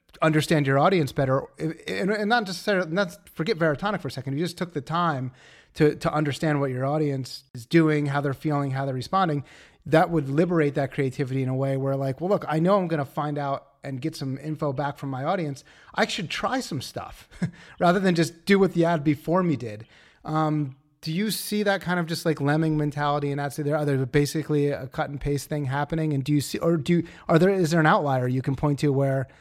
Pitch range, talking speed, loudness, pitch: 140-170 Hz, 235 wpm, -25 LUFS, 150 Hz